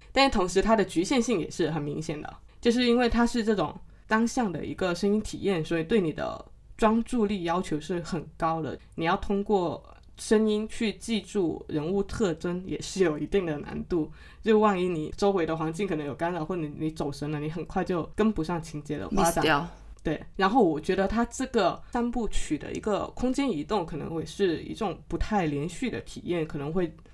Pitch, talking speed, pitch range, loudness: 185 Hz, 295 characters per minute, 160-220 Hz, -28 LUFS